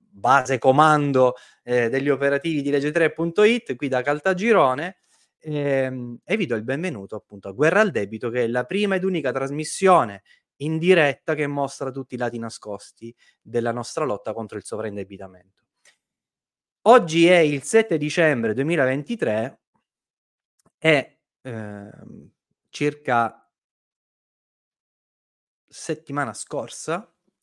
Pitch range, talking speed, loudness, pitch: 120-160 Hz, 115 wpm, -21 LUFS, 140 Hz